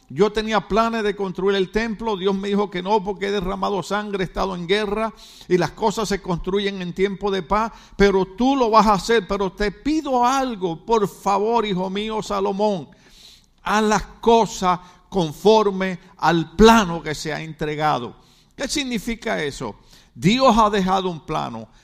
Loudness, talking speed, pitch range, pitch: -20 LUFS, 170 wpm, 185-220 Hz, 200 Hz